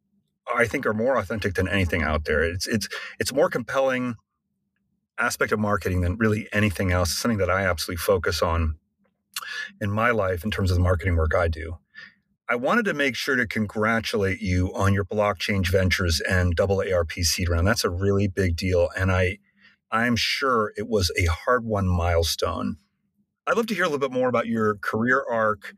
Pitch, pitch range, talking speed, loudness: 100 Hz, 90-115 Hz, 200 wpm, -24 LUFS